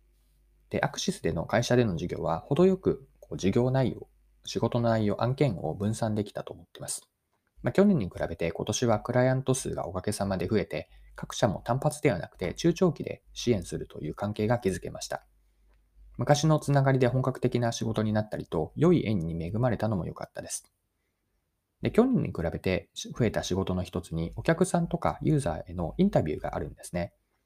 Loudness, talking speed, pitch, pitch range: -29 LUFS, 380 characters per minute, 110 Hz, 90-130 Hz